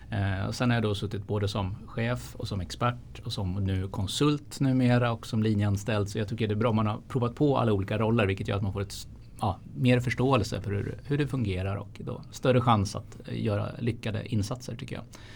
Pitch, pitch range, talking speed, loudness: 110 Hz, 100-125 Hz, 225 wpm, -29 LUFS